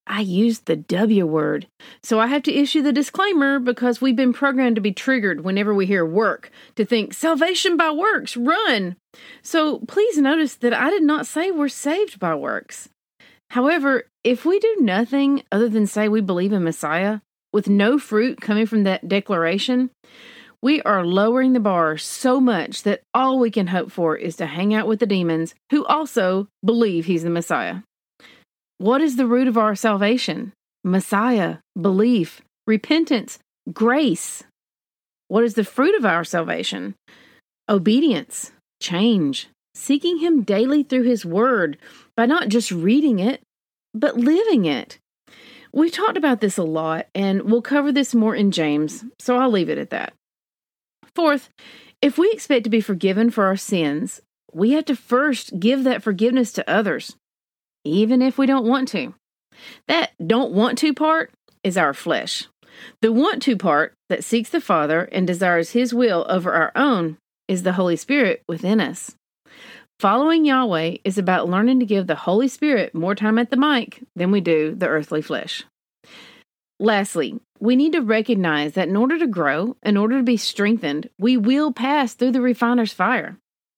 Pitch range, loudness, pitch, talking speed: 195-265 Hz, -20 LUFS, 230 Hz, 170 wpm